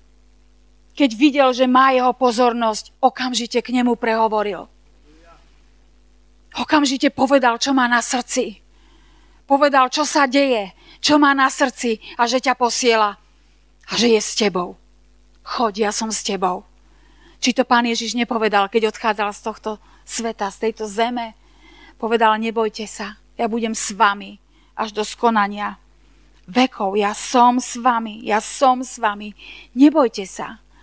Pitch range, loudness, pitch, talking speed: 215-260 Hz, -18 LUFS, 235 Hz, 140 wpm